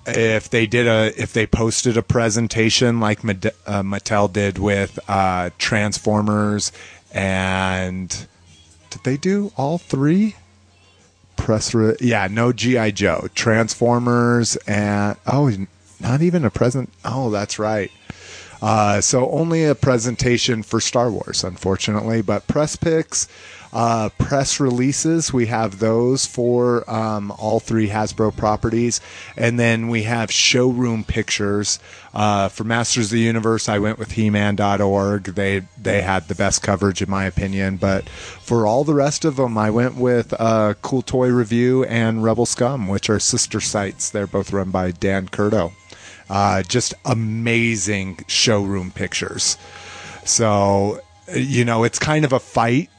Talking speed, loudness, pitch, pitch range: 145 wpm, -19 LUFS, 110 Hz, 100-120 Hz